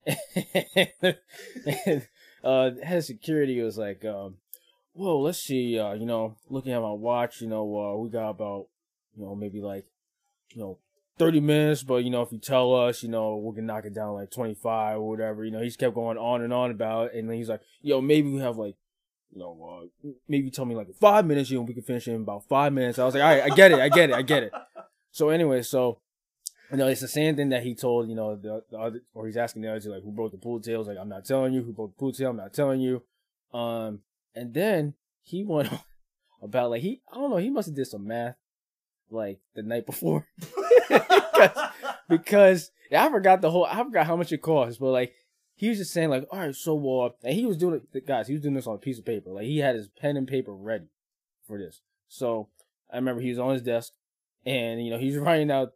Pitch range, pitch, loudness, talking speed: 110-150 Hz, 125 Hz, -25 LUFS, 250 wpm